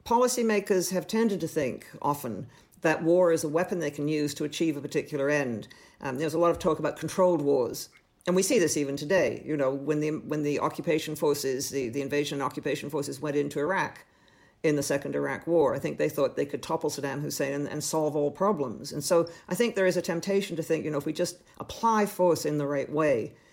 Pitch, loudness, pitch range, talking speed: 155 Hz, -28 LUFS, 145-175 Hz, 230 wpm